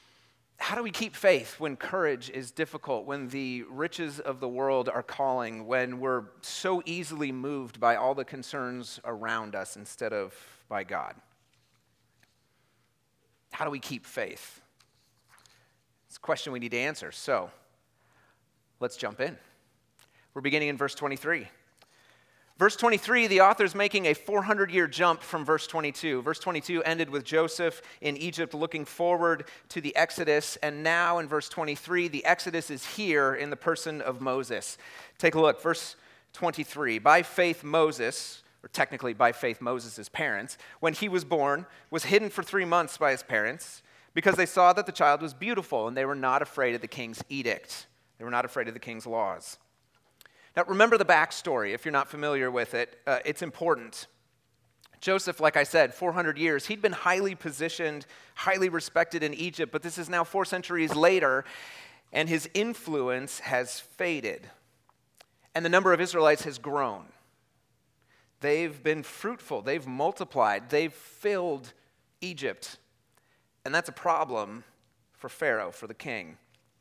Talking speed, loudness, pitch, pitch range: 160 wpm, -28 LUFS, 155 Hz, 135-175 Hz